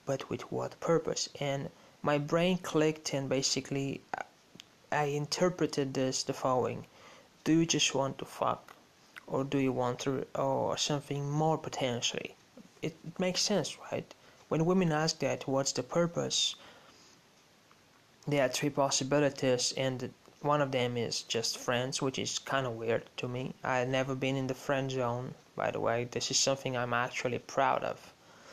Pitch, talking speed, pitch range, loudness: 135 Hz, 160 wpm, 130-150 Hz, -32 LUFS